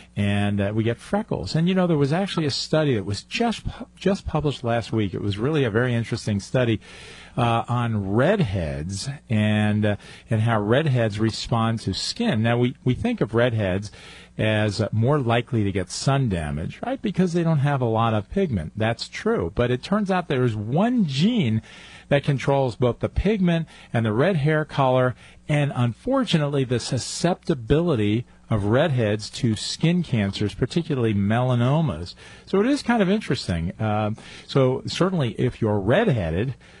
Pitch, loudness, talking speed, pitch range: 120 Hz, -23 LUFS, 170 wpm, 110-155 Hz